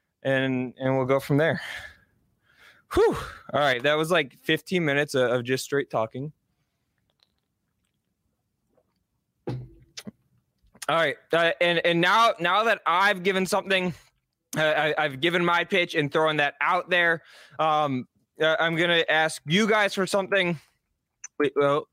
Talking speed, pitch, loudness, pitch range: 140 wpm, 160 Hz, -24 LUFS, 140-180 Hz